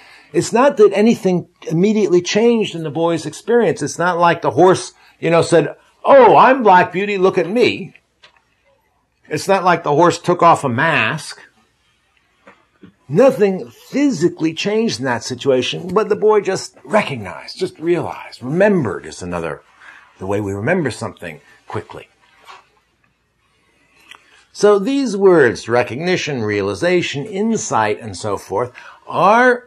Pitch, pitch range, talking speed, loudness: 180 Hz, 150-210 Hz, 135 wpm, -15 LUFS